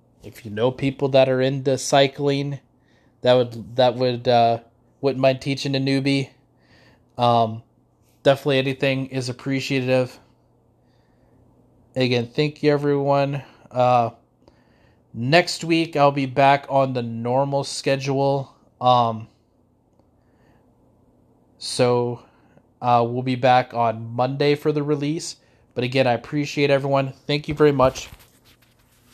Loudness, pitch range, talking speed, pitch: -21 LUFS, 125-140 Hz, 115 wpm, 135 Hz